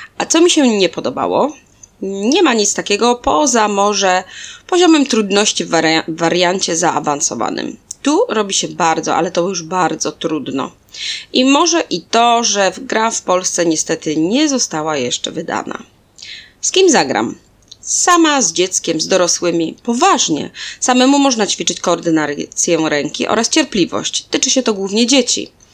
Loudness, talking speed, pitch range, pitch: -14 LUFS, 140 wpm, 165-260 Hz, 200 Hz